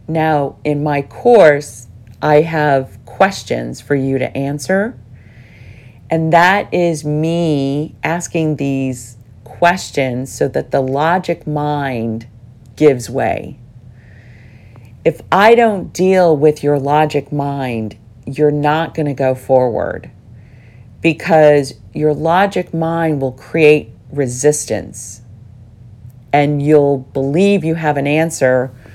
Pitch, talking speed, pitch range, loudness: 140 Hz, 110 wpm, 120-155 Hz, -14 LUFS